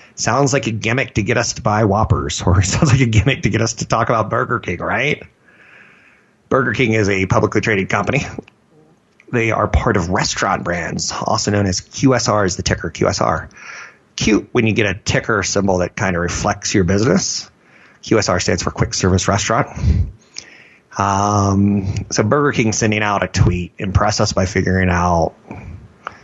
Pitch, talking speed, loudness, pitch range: 105 Hz, 175 wpm, -17 LUFS, 95-115 Hz